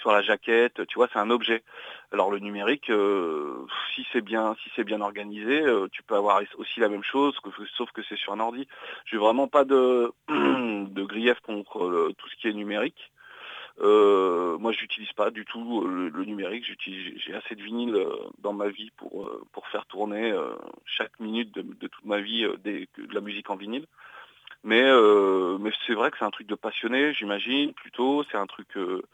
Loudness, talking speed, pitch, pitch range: -26 LUFS, 200 wpm, 115 Hz, 105-135 Hz